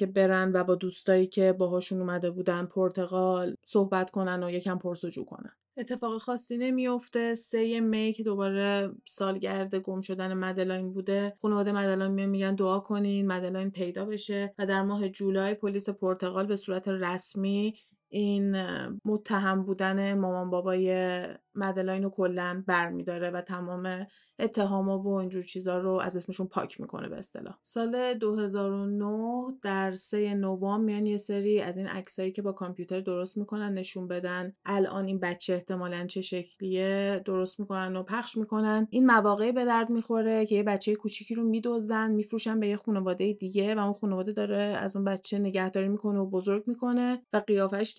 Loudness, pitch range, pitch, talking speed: -30 LUFS, 185-210 Hz, 195 Hz, 160 wpm